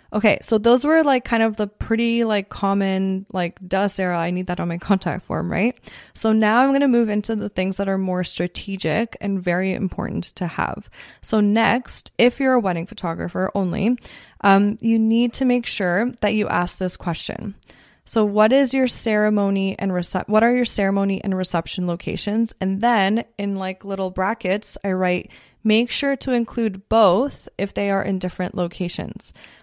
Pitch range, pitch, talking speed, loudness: 185-225 Hz, 200 Hz, 185 wpm, -21 LUFS